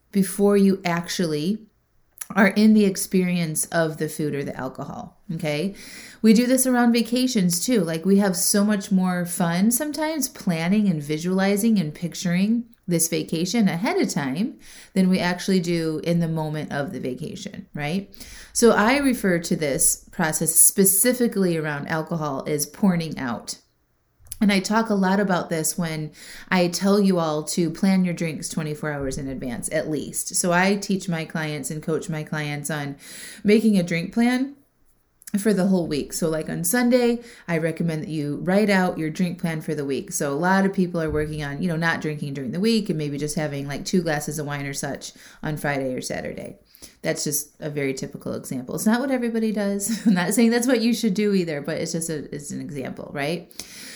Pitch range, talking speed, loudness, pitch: 155-210 Hz, 195 wpm, -22 LUFS, 180 Hz